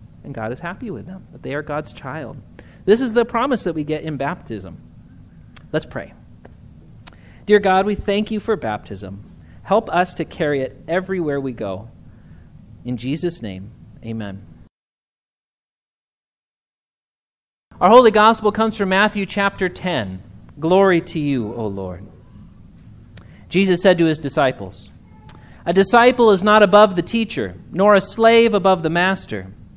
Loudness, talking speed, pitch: -17 LUFS, 145 wpm, 155 Hz